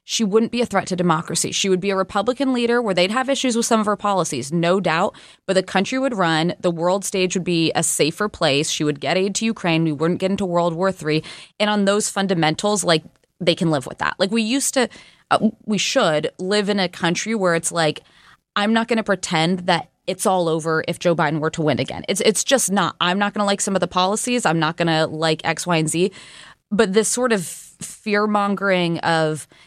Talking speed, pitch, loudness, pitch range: 240 wpm, 185 Hz, -20 LUFS, 165-210 Hz